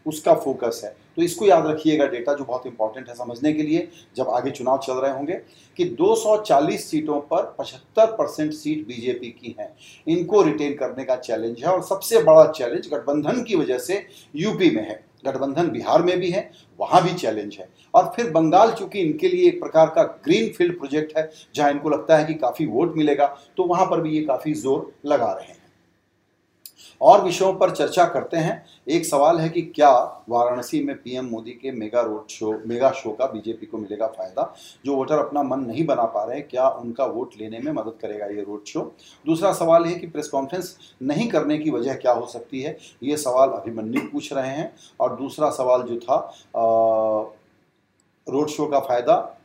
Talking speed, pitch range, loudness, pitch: 195 wpm, 125-180 Hz, -21 LUFS, 150 Hz